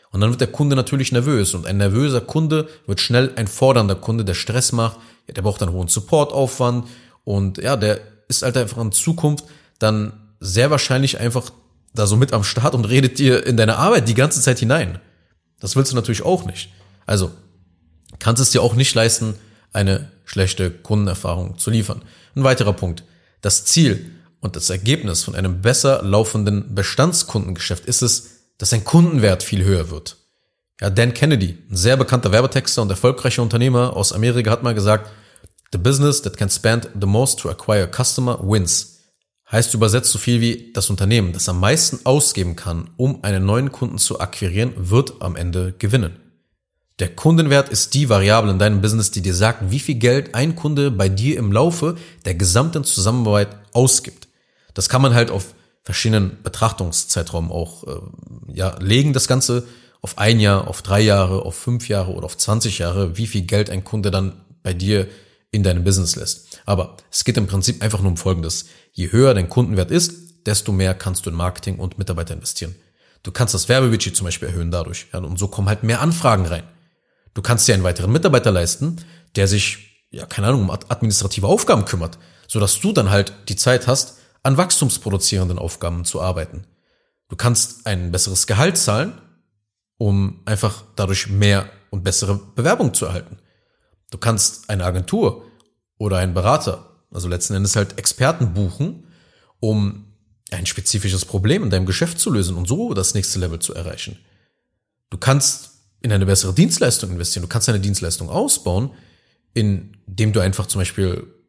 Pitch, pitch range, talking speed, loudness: 105 Hz, 95-125 Hz, 180 wpm, -17 LUFS